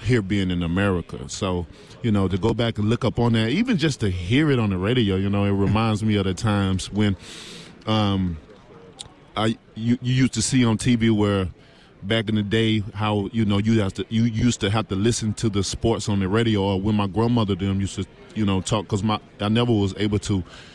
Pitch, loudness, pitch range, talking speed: 105 Hz, -22 LUFS, 100-115 Hz, 235 wpm